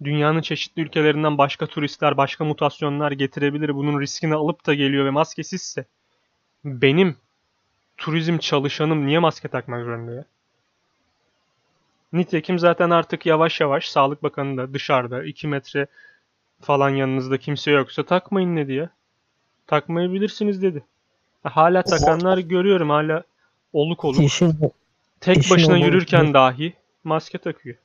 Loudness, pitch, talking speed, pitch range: -20 LUFS, 150 Hz, 120 wpm, 140-170 Hz